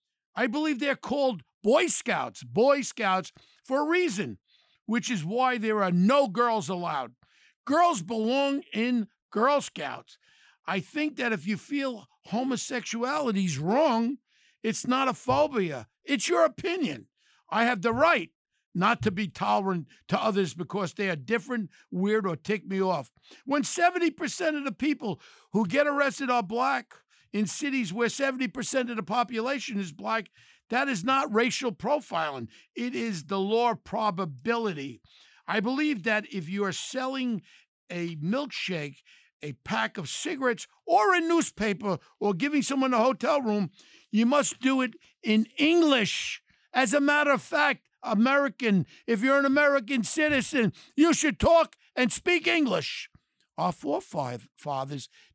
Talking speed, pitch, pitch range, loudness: 145 wpm, 240 Hz, 205-280 Hz, -27 LUFS